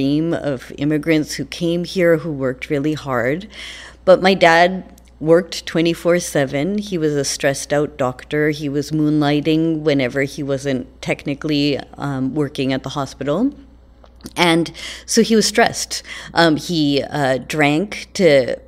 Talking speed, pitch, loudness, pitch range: 140 wpm, 150 Hz, -18 LUFS, 140-170 Hz